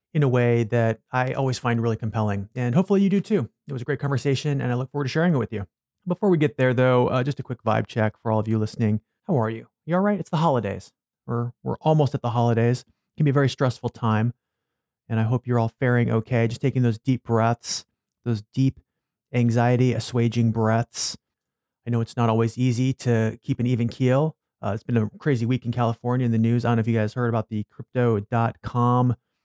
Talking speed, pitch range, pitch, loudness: 235 wpm, 115-130 Hz, 120 Hz, -23 LUFS